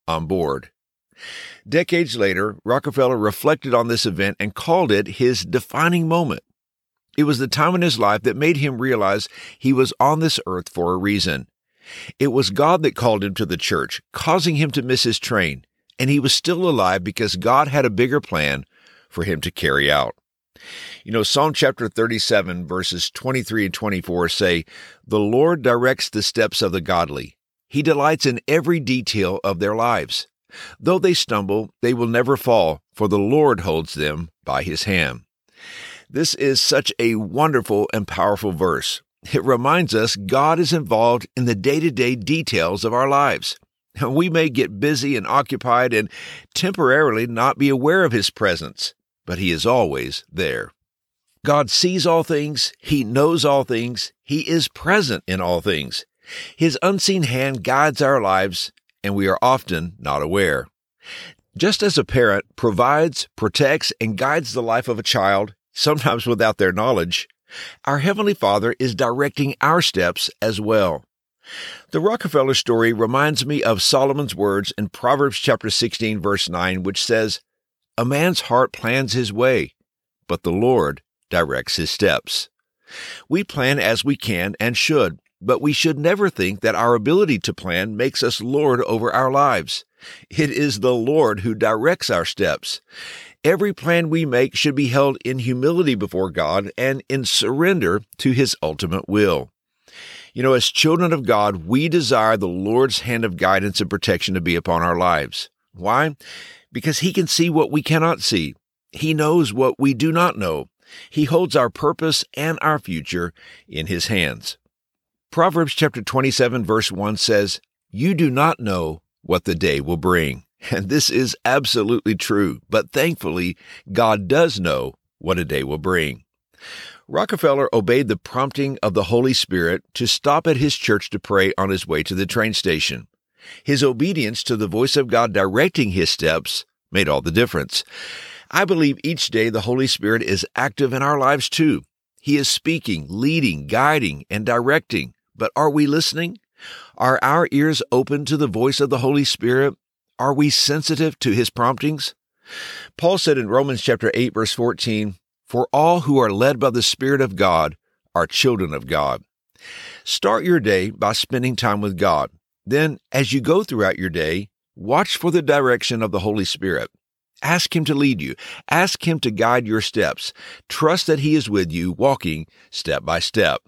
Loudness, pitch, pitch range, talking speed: -19 LUFS, 130 Hz, 105-150 Hz, 170 wpm